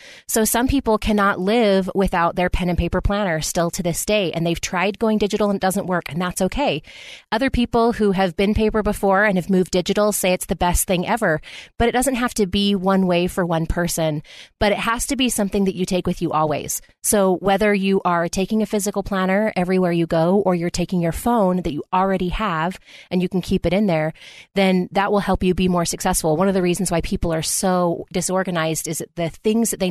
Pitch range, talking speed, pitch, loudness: 175-210 Hz, 235 wpm, 190 Hz, -20 LUFS